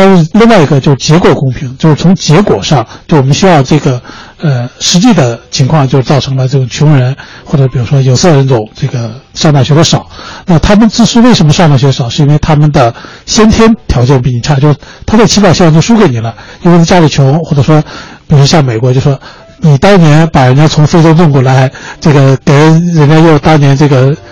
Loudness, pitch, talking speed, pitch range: -6 LUFS, 150 Hz, 325 characters per minute, 135-165 Hz